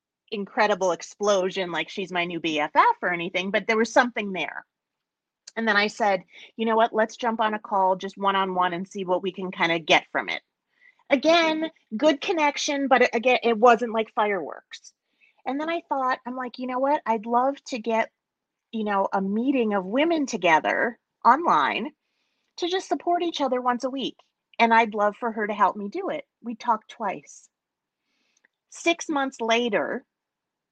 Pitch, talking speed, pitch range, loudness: 225 Hz, 185 wpm, 195-270 Hz, -24 LUFS